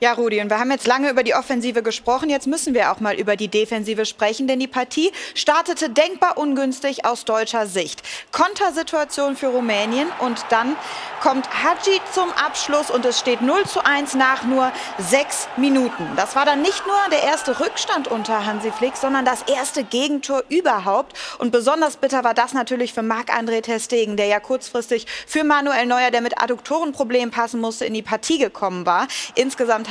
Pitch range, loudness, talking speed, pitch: 230-290 Hz, -20 LUFS, 180 wpm, 255 Hz